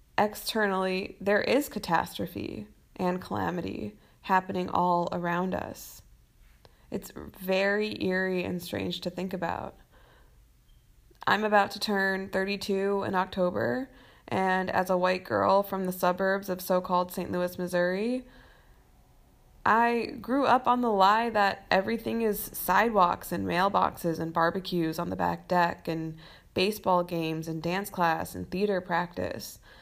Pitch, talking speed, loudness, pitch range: 185 Hz, 135 wpm, -28 LUFS, 175-200 Hz